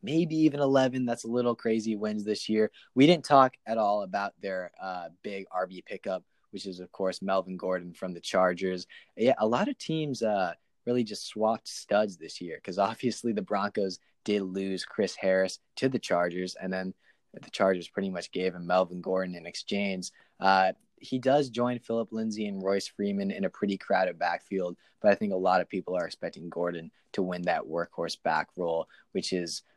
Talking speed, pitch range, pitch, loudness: 195 wpm, 95-115 Hz, 100 Hz, -29 LUFS